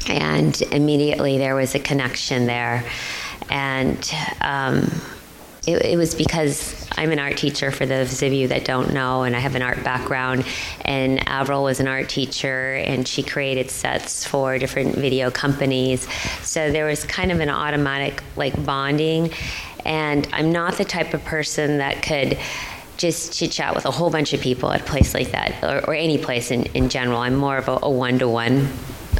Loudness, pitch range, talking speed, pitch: -21 LUFS, 130-150 Hz, 185 wpm, 135 Hz